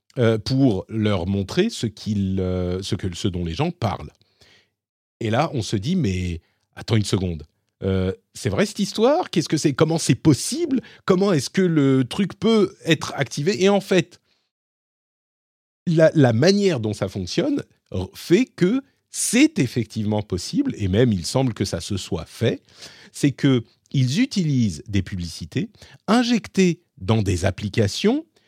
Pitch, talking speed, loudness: 120 Hz, 145 wpm, -21 LUFS